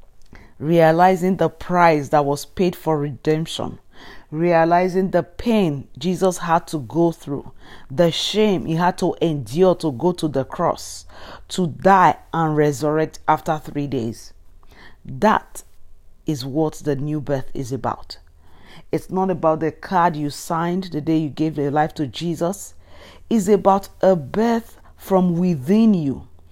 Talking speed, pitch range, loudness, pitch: 145 wpm, 140-180 Hz, -20 LUFS, 160 Hz